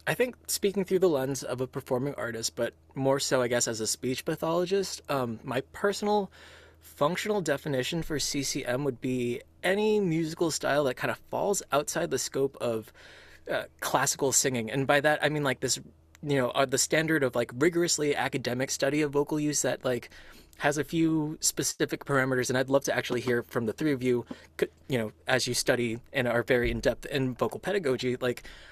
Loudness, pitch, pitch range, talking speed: -28 LUFS, 135 Hz, 125-150 Hz, 190 wpm